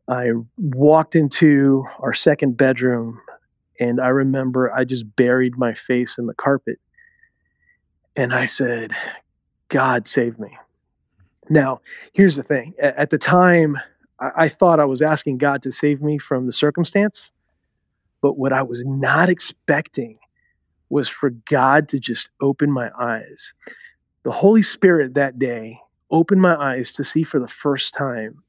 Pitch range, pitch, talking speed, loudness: 125-155 Hz, 140 Hz, 145 wpm, -18 LUFS